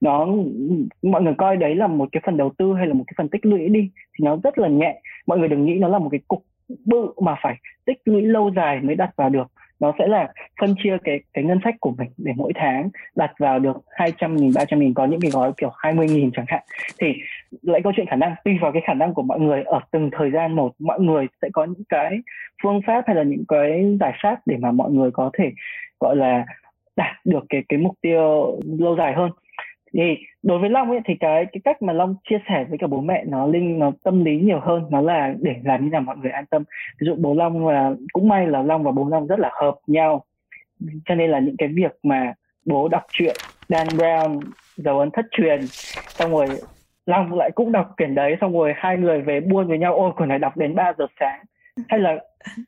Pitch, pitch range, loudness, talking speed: 165 Hz, 145-195 Hz, -20 LUFS, 245 wpm